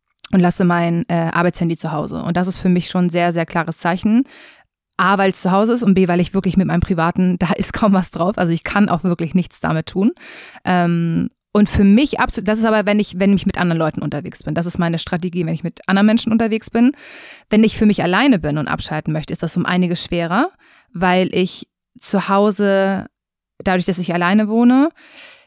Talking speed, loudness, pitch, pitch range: 225 wpm, -17 LUFS, 185 Hz, 175-215 Hz